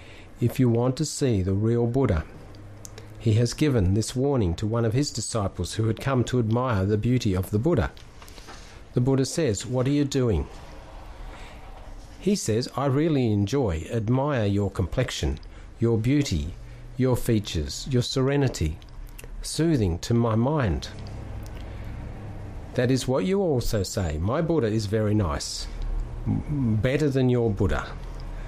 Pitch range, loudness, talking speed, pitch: 100-130 Hz, -25 LUFS, 145 wpm, 110 Hz